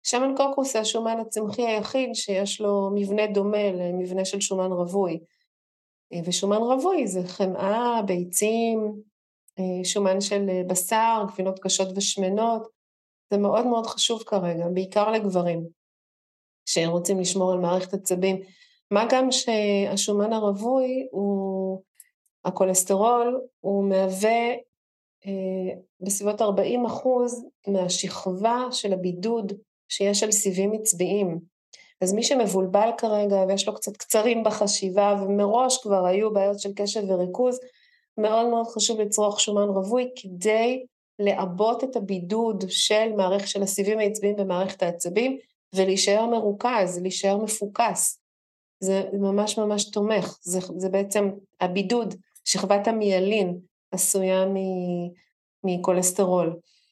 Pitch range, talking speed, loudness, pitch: 190-220 Hz, 110 wpm, -24 LUFS, 200 Hz